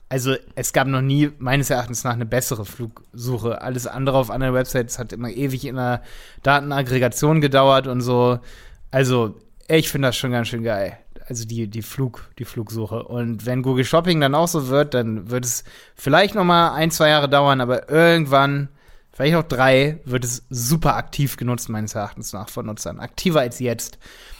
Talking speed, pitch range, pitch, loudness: 185 wpm, 120-140 Hz, 130 Hz, -20 LUFS